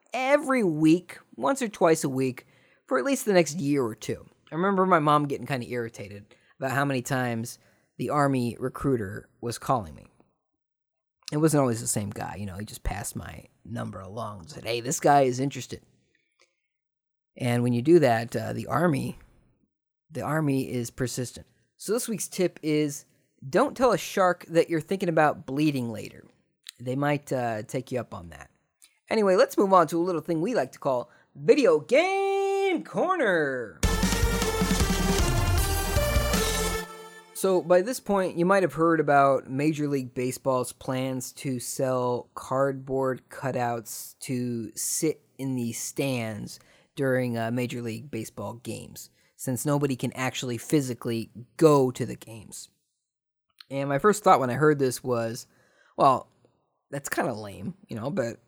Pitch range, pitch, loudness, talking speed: 120-155 Hz, 130 Hz, -26 LUFS, 160 wpm